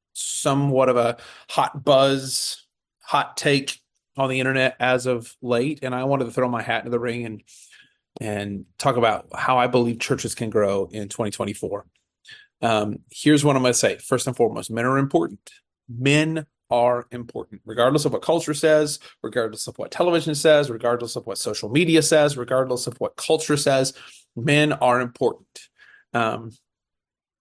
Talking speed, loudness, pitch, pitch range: 165 wpm, -22 LUFS, 125 Hz, 120-145 Hz